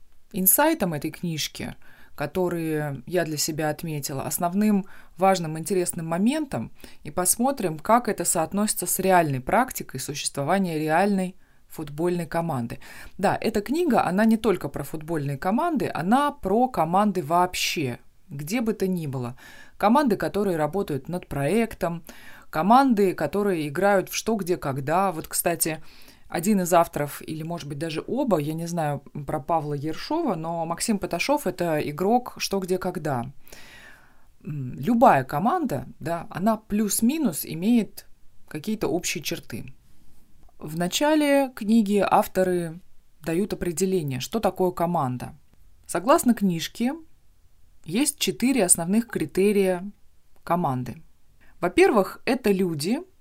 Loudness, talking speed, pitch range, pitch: -24 LUFS, 120 wpm, 160-205 Hz, 180 Hz